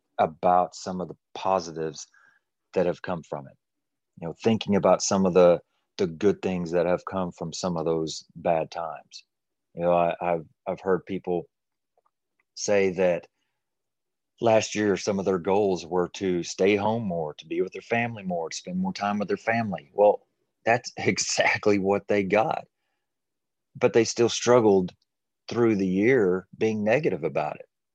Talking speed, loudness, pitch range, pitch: 170 wpm, -25 LUFS, 90-105 Hz, 95 Hz